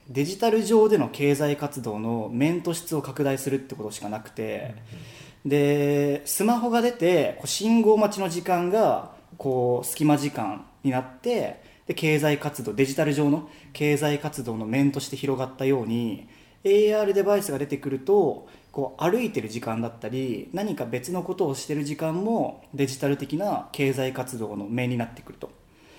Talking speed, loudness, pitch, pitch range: 315 characters per minute, -25 LUFS, 145 Hz, 130-165 Hz